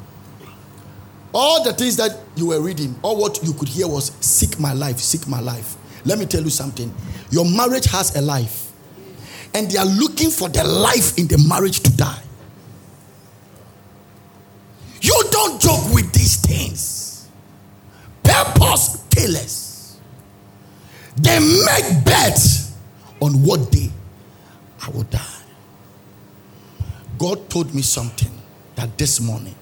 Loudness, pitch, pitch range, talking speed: -17 LUFS, 120 Hz, 100-150 Hz, 130 wpm